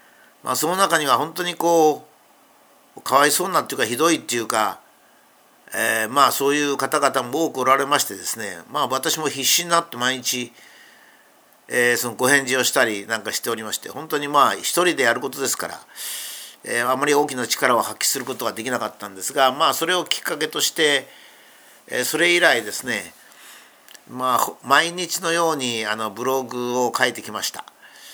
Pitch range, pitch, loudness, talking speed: 125-155 Hz, 135 Hz, -20 LUFS, 335 characters per minute